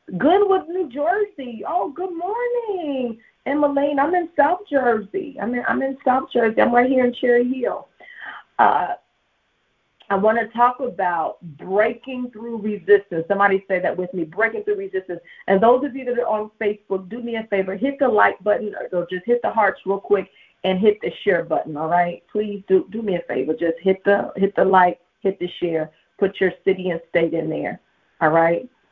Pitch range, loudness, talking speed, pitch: 190-255 Hz, -21 LUFS, 195 wpm, 210 Hz